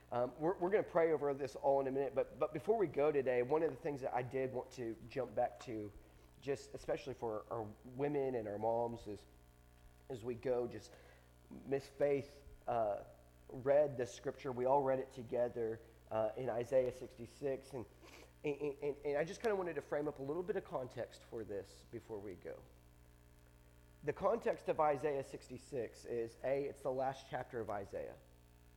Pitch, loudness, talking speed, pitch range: 125 Hz, -40 LUFS, 195 wpm, 105-140 Hz